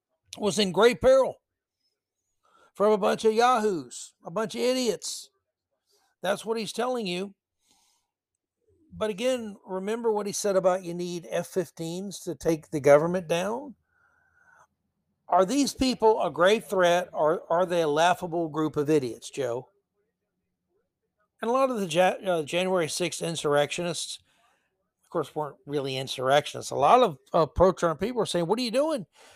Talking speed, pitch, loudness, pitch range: 145 wpm, 195 Hz, -26 LUFS, 170-240 Hz